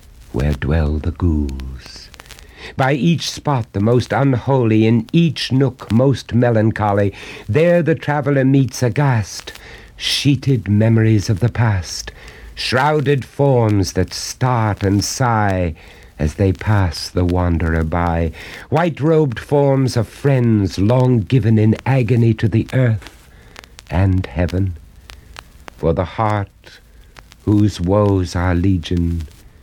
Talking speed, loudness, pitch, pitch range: 115 wpm, -17 LUFS, 105 Hz, 85-125 Hz